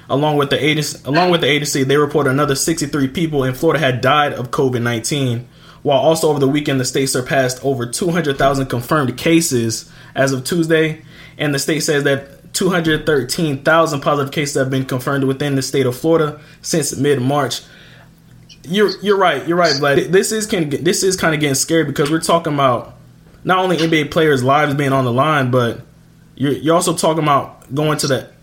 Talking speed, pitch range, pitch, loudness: 190 wpm, 135-160 Hz, 150 Hz, -16 LUFS